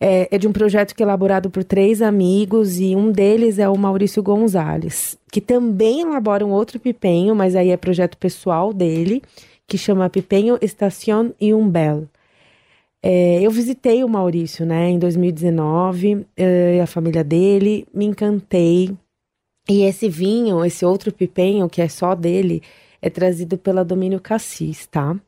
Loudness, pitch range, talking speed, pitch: -17 LUFS, 180-210 Hz, 155 wpm, 195 Hz